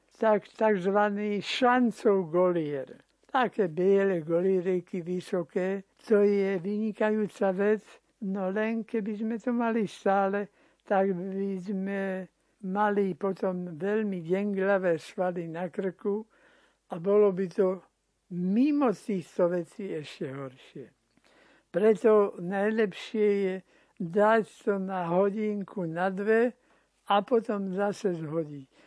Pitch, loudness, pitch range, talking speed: 195 Hz, -28 LUFS, 185-215 Hz, 105 wpm